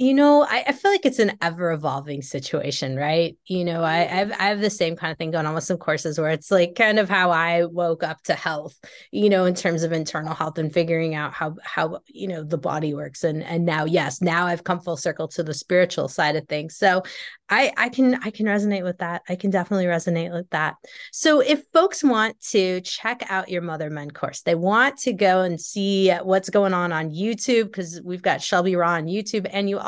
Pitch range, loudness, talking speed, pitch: 160-200 Hz, -22 LUFS, 235 wpm, 175 Hz